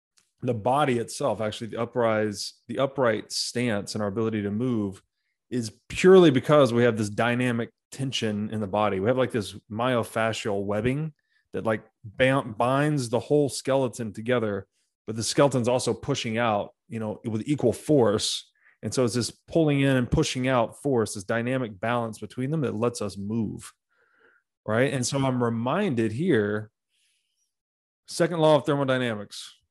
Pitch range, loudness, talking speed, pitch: 110-130 Hz, -25 LUFS, 160 wpm, 120 Hz